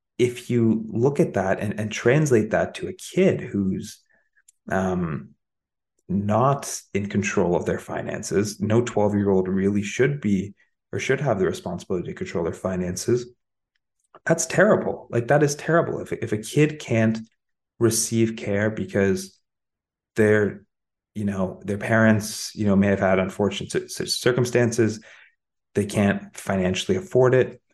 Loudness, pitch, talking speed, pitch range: -23 LUFS, 105 Hz, 145 wpm, 100-120 Hz